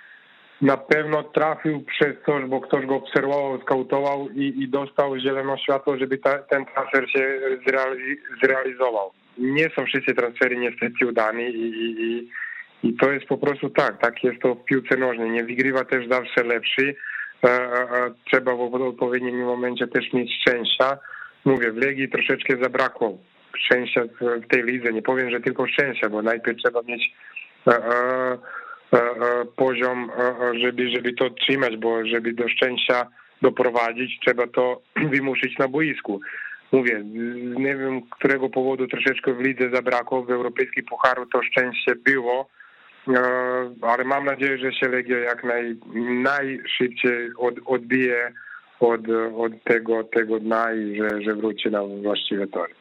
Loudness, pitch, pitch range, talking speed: -22 LUFS, 125 Hz, 120-135 Hz, 145 wpm